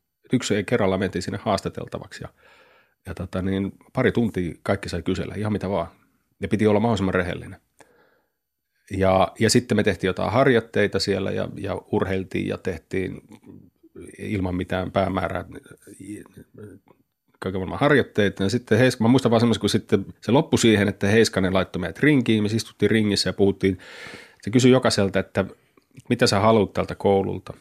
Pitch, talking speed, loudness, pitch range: 100 Hz, 150 wpm, -22 LUFS, 95-115 Hz